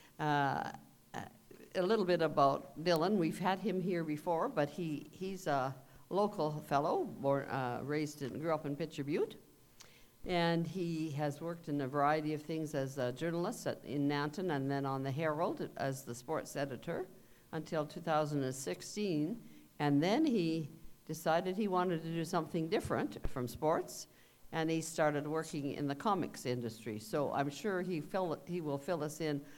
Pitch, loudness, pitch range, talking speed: 155 Hz, -37 LUFS, 140-170 Hz, 180 wpm